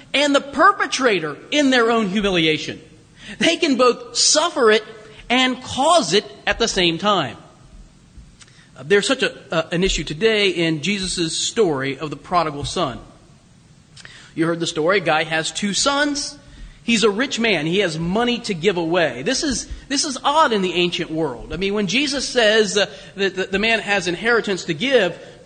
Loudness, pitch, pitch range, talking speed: -18 LUFS, 205 Hz, 170-245 Hz, 175 wpm